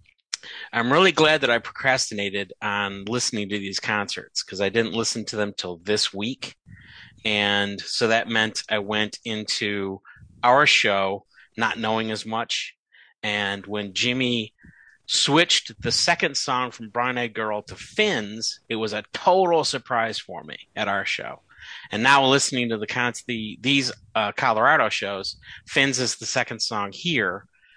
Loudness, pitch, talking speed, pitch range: -23 LUFS, 110 Hz, 160 wpm, 105-125 Hz